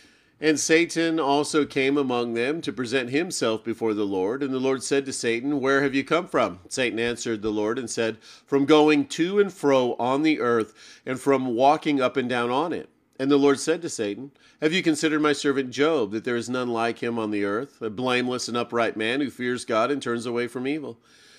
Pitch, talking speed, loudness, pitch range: 135 Hz, 220 wpm, -24 LUFS, 120-145 Hz